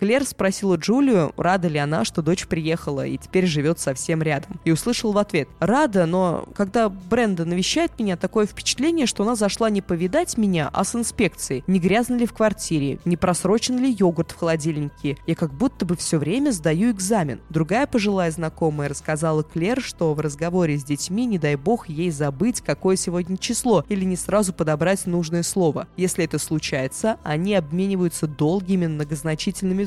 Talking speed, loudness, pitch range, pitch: 170 wpm, -22 LUFS, 160-210 Hz, 180 Hz